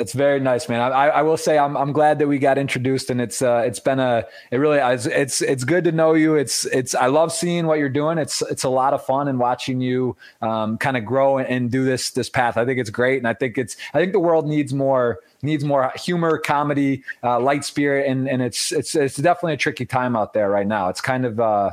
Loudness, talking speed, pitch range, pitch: -20 LUFS, 260 wpm, 125-145 Hz, 135 Hz